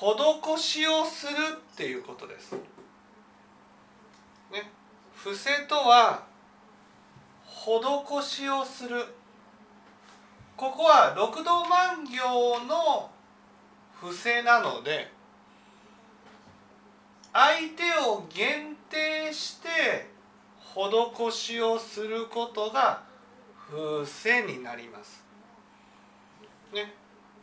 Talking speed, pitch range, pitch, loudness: 130 characters per minute, 220-310 Hz, 245 Hz, -26 LUFS